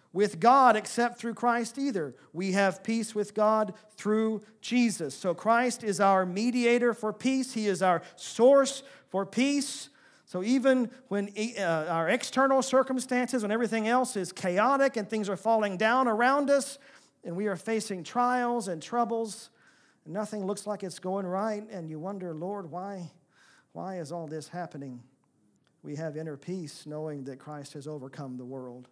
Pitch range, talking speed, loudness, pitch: 180-240 Hz, 160 wpm, -28 LUFS, 210 Hz